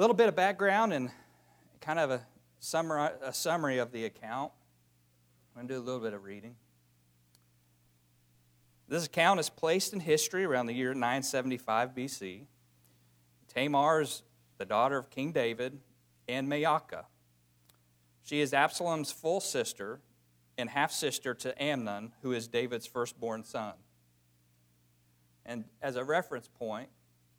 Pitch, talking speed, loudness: 115 Hz, 140 wpm, -32 LUFS